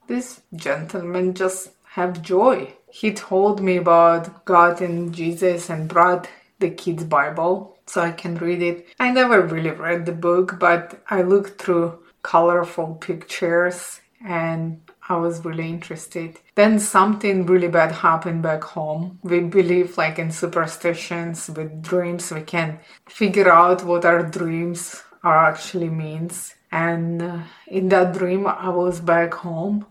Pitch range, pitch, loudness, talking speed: 170-185 Hz, 175 Hz, -20 LUFS, 140 wpm